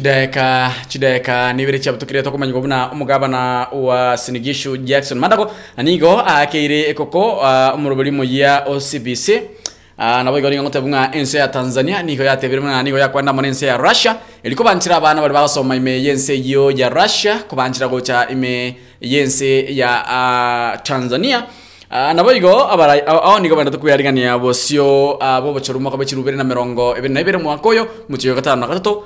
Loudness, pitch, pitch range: -14 LUFS, 135 Hz, 130-145 Hz